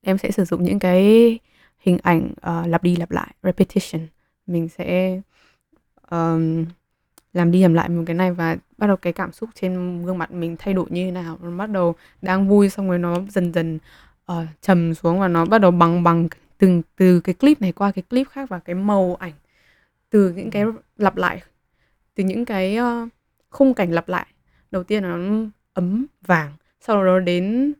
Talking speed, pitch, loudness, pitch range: 200 wpm, 185 Hz, -20 LUFS, 170-200 Hz